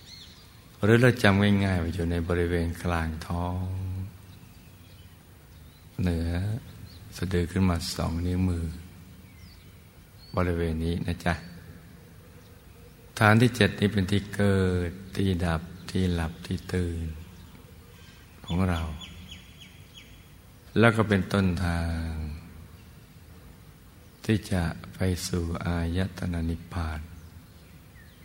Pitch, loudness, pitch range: 90 Hz, -27 LUFS, 85-95 Hz